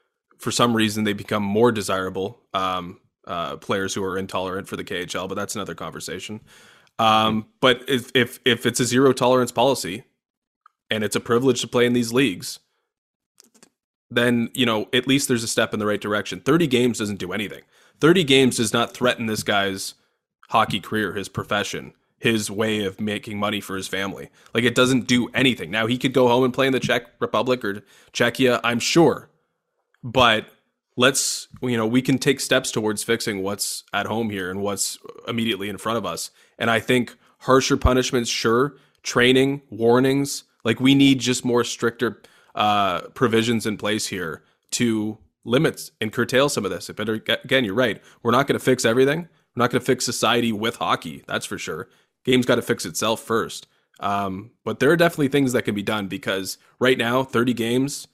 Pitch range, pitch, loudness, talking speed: 105-125 Hz, 120 Hz, -21 LUFS, 190 wpm